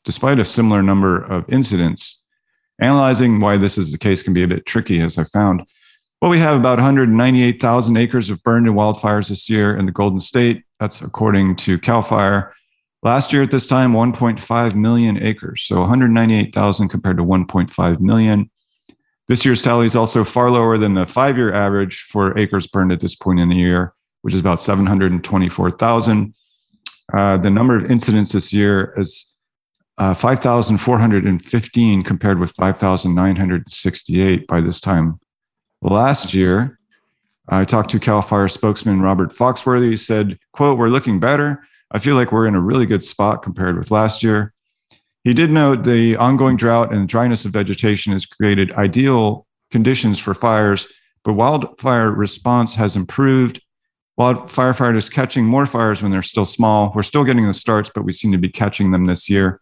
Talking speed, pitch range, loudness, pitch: 180 wpm, 95-120 Hz, -16 LUFS, 105 Hz